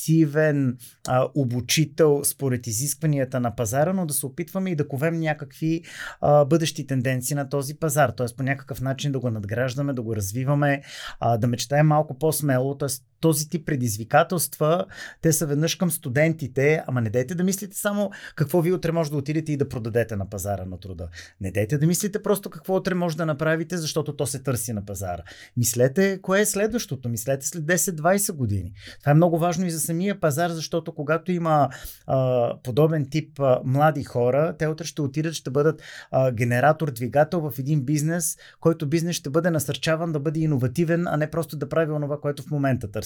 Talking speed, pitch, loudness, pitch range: 185 wpm, 150 Hz, -24 LUFS, 130-165 Hz